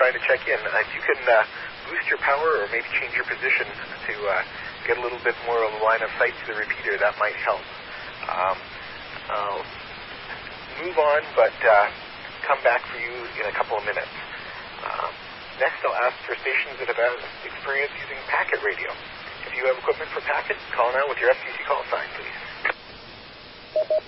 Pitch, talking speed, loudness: 145 Hz, 185 wpm, -24 LUFS